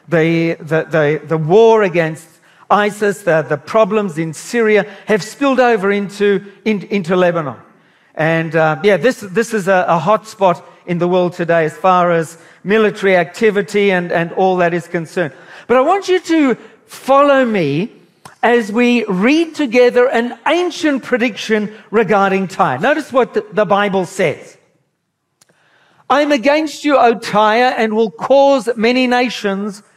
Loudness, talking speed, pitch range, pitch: -14 LUFS, 150 wpm, 175-245 Hz, 210 Hz